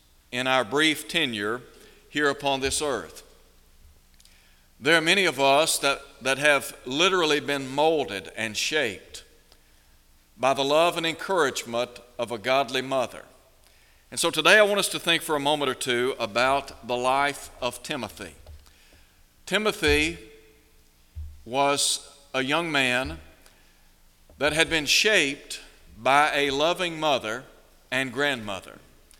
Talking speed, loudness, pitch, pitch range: 130 wpm, -24 LUFS, 135 Hz, 90-150 Hz